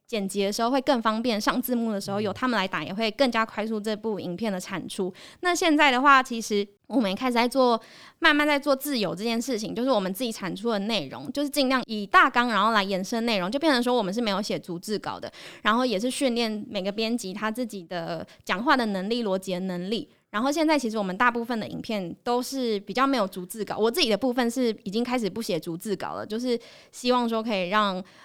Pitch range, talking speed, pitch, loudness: 200-255 Hz, 355 characters per minute, 225 Hz, -25 LUFS